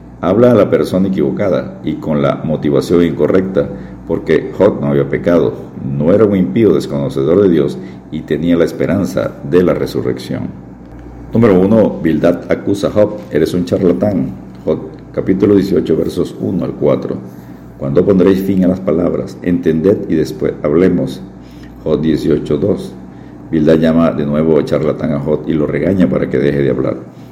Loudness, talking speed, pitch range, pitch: -13 LUFS, 165 wpm, 65-90 Hz, 75 Hz